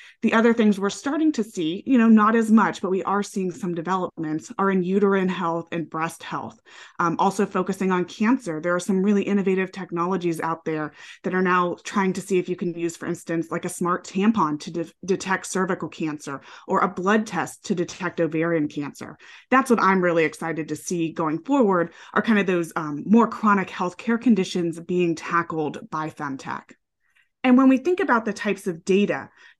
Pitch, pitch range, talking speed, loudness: 185 Hz, 165-205 Hz, 200 wpm, -23 LUFS